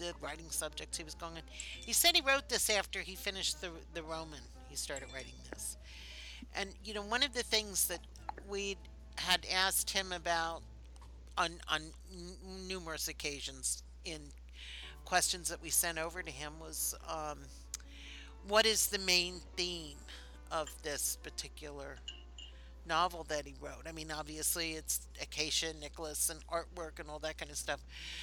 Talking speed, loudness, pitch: 165 wpm, -36 LUFS, 155 Hz